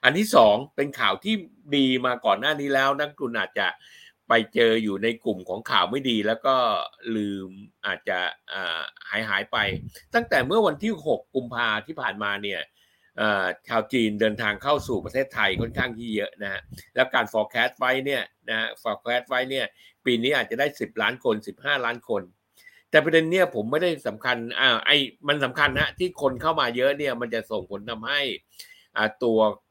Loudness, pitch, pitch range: -24 LUFS, 125 Hz, 110-145 Hz